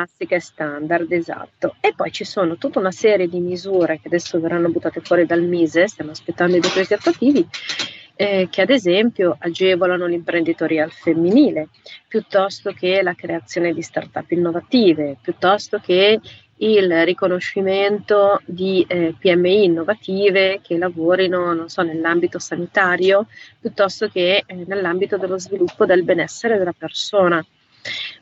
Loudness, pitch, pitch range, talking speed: -18 LUFS, 180 Hz, 170-195 Hz, 130 wpm